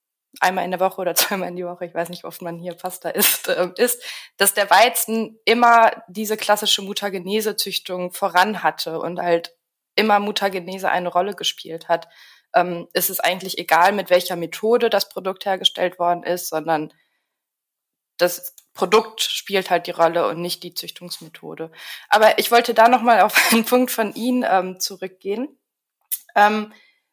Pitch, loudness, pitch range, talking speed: 190 Hz, -19 LUFS, 175-215 Hz, 165 wpm